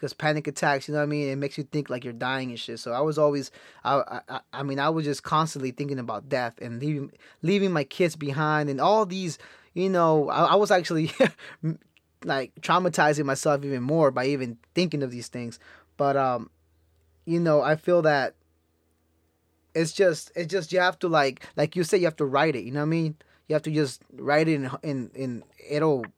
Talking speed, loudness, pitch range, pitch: 220 wpm, -26 LUFS, 130-160 Hz, 145 Hz